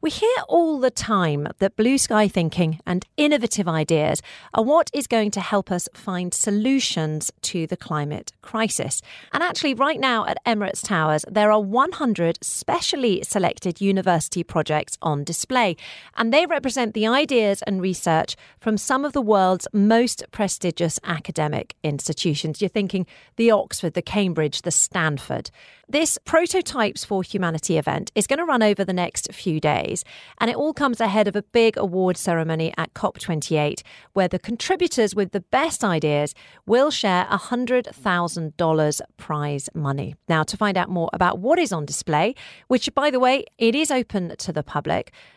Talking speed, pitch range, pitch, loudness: 165 wpm, 165-235 Hz, 195 Hz, -22 LUFS